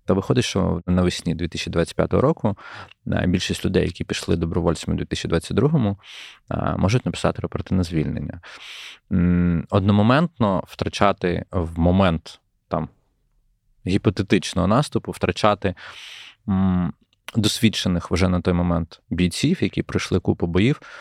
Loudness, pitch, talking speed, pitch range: -22 LUFS, 95 Hz, 95 wpm, 90-105 Hz